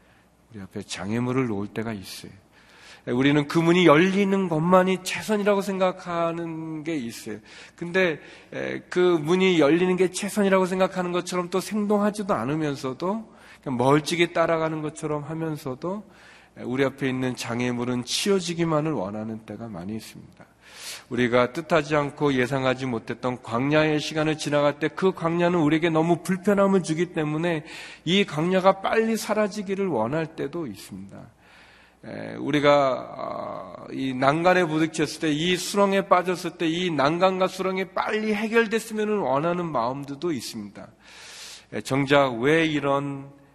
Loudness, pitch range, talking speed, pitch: -24 LUFS, 130-185 Hz, 315 characters per minute, 160 Hz